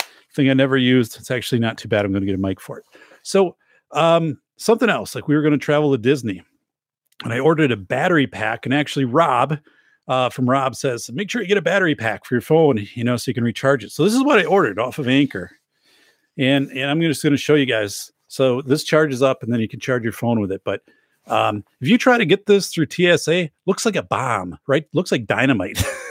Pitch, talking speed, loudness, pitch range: 135 Hz, 245 wpm, -19 LUFS, 120-160 Hz